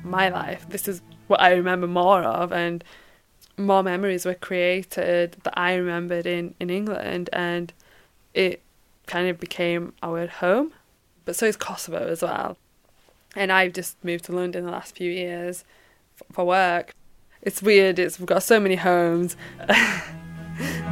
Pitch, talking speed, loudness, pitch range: 180 Hz, 155 wpm, -23 LUFS, 175-190 Hz